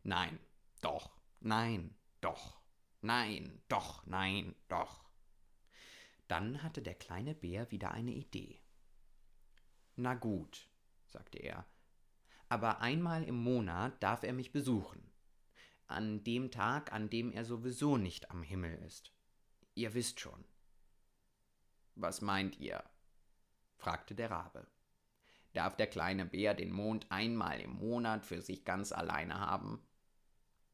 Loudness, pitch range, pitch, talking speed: -40 LUFS, 95-120 Hz, 110 Hz, 120 wpm